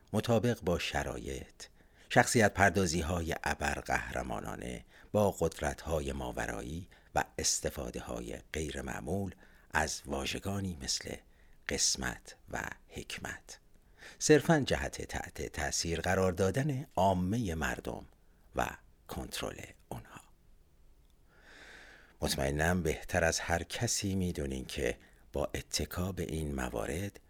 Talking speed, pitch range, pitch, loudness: 100 wpm, 70-95 Hz, 85 Hz, -34 LUFS